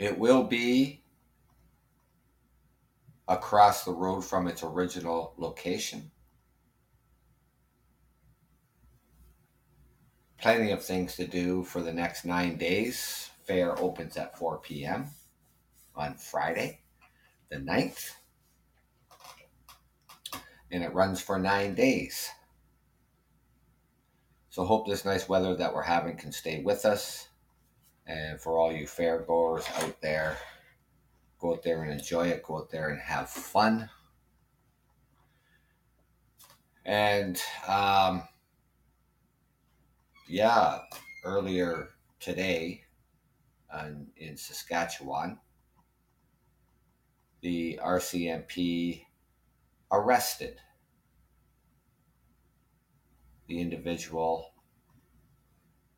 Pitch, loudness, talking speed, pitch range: 90 Hz, -30 LUFS, 85 wpm, 80-95 Hz